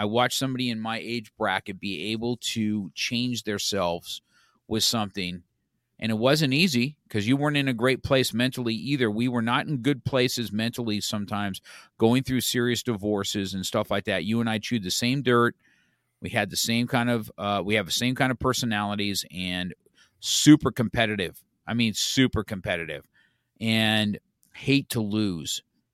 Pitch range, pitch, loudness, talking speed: 105-125 Hz, 115 Hz, -25 LUFS, 175 wpm